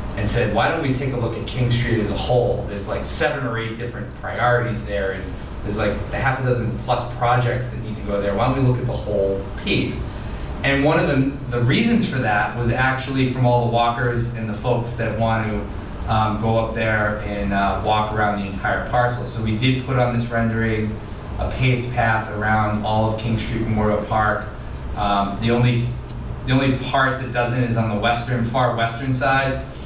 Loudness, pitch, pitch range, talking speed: -21 LUFS, 115 Hz, 105-125 Hz, 215 wpm